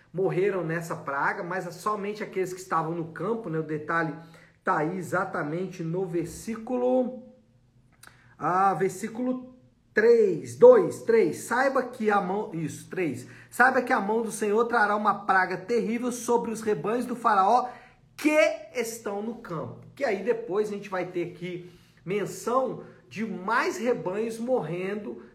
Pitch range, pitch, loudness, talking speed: 175-240 Hz, 205 Hz, -26 LUFS, 145 wpm